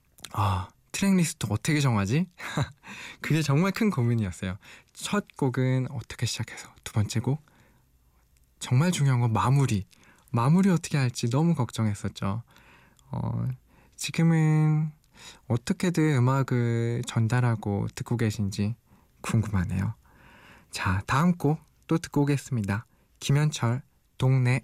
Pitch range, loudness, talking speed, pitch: 105-150 Hz, -27 LUFS, 250 characters per minute, 125 Hz